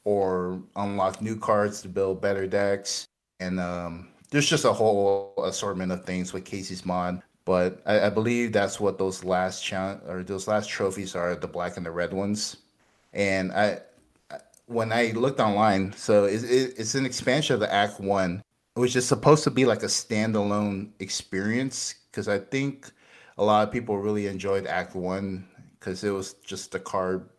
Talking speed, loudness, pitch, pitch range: 175 wpm, -26 LUFS, 100 Hz, 95-110 Hz